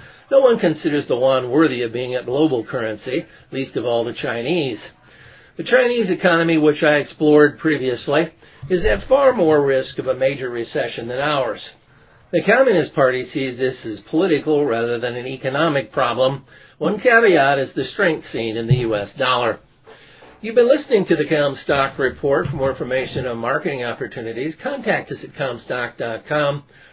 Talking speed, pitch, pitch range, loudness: 165 wpm, 140 Hz, 130-160 Hz, -19 LUFS